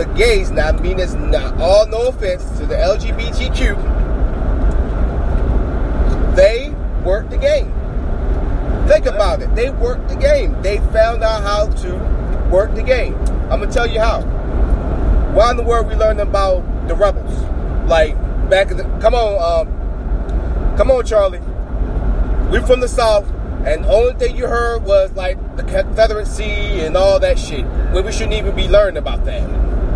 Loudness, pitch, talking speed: -16 LUFS, 210 Hz, 160 wpm